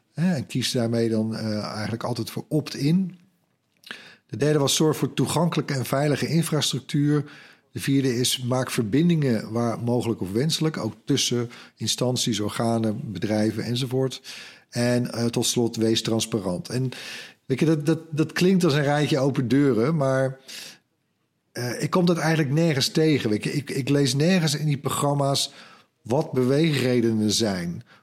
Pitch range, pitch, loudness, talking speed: 115-150 Hz, 130 Hz, -23 LUFS, 150 wpm